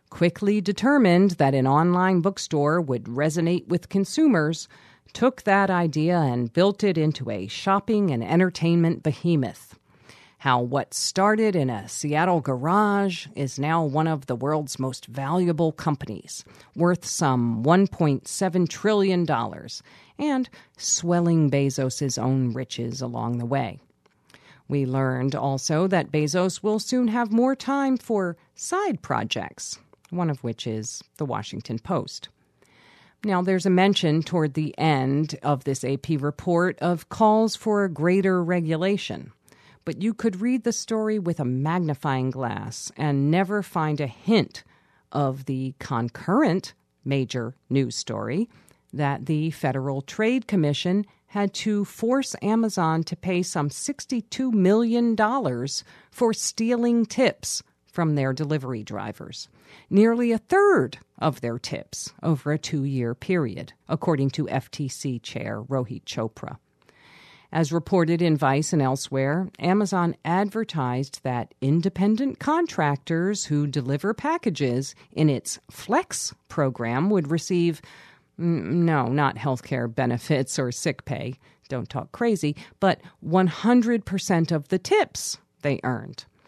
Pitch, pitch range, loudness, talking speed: 160 Hz, 135-195 Hz, -24 LUFS, 125 wpm